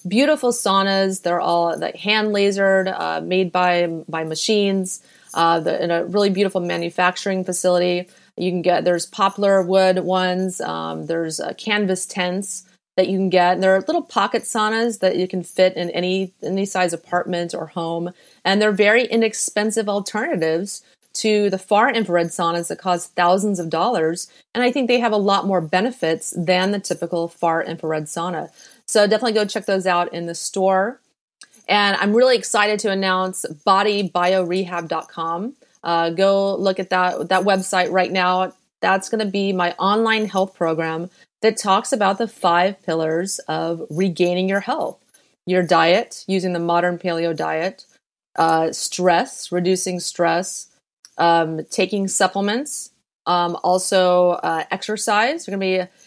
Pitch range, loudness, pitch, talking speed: 175-200 Hz, -19 LUFS, 185 Hz, 155 wpm